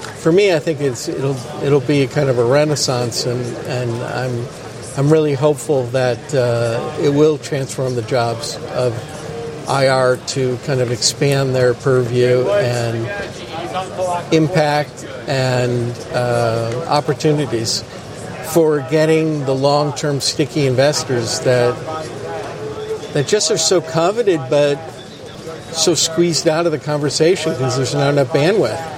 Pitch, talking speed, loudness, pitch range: 140 Hz, 130 wpm, -17 LUFS, 125-155 Hz